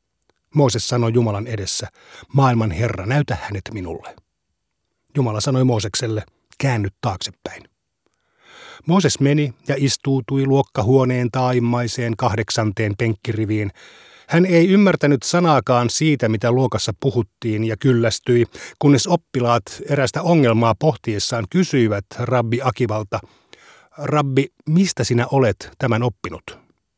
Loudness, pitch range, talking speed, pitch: -19 LUFS, 110-140 Hz, 100 wpm, 125 Hz